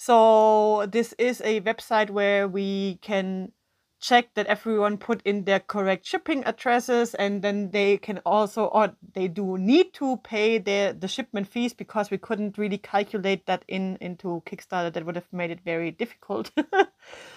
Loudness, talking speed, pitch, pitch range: -25 LUFS, 165 wpm, 210 Hz, 195-230 Hz